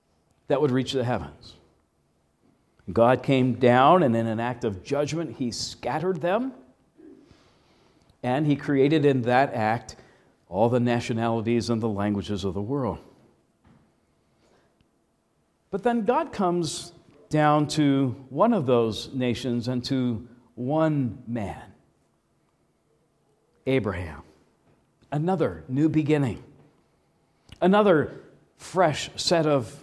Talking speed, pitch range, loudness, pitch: 110 wpm, 115-150 Hz, -24 LUFS, 125 Hz